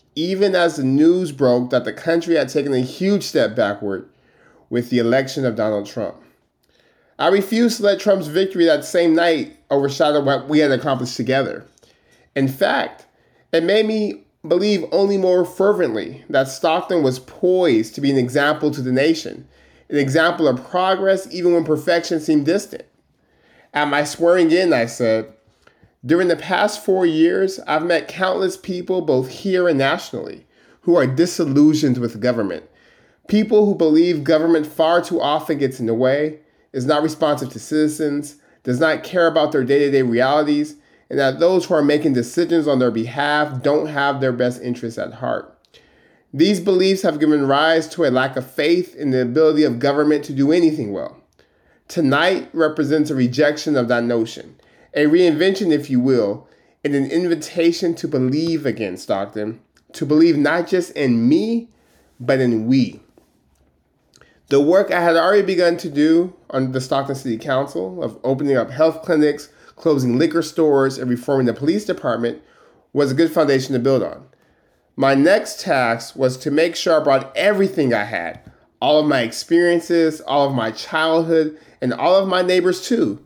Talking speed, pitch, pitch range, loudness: 170 wpm, 150 Hz, 130-170 Hz, -18 LUFS